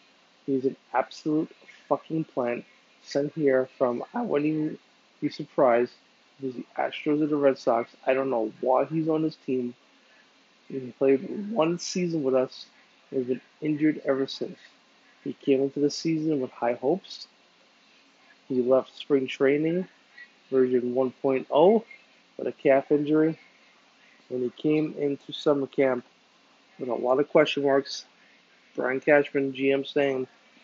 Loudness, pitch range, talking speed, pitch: -26 LUFS, 130-155 Hz, 145 wpm, 140 Hz